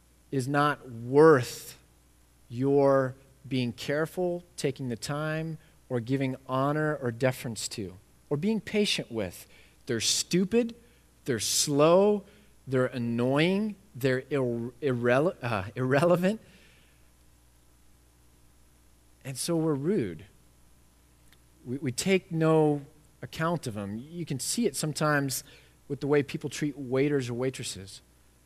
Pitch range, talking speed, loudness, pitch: 105-155 Hz, 115 wpm, -28 LUFS, 135 Hz